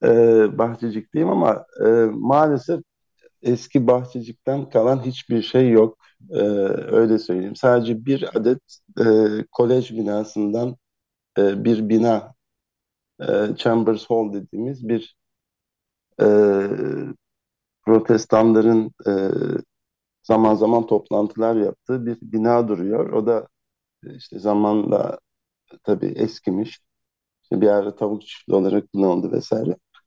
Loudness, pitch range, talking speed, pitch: -20 LUFS, 105-120 Hz, 100 wpm, 115 Hz